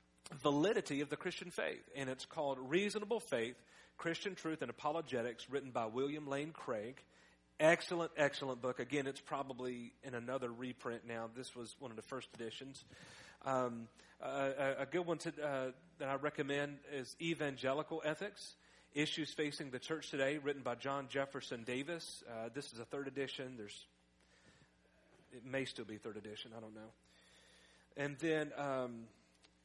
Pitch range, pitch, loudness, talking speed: 120-150 Hz, 135 Hz, -42 LUFS, 160 wpm